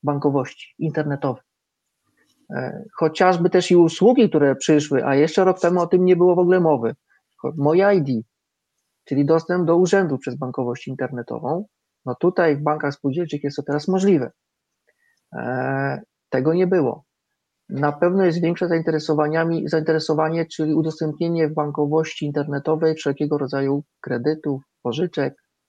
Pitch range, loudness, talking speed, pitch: 140-175 Hz, -20 LUFS, 125 wpm, 155 Hz